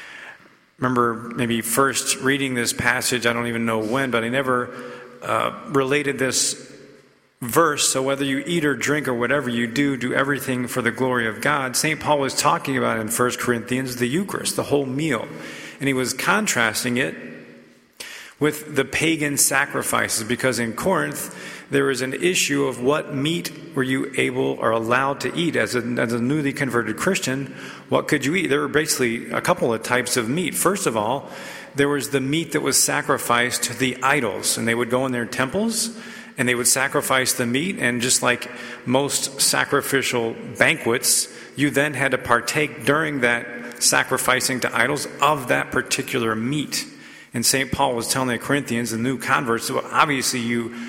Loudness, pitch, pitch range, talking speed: -21 LUFS, 130 Hz, 120-140 Hz, 180 wpm